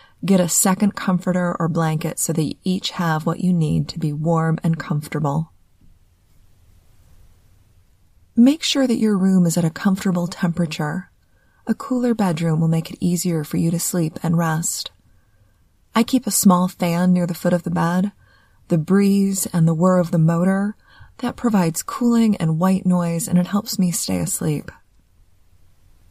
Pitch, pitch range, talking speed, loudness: 170 Hz, 150-190 Hz, 170 wpm, -19 LUFS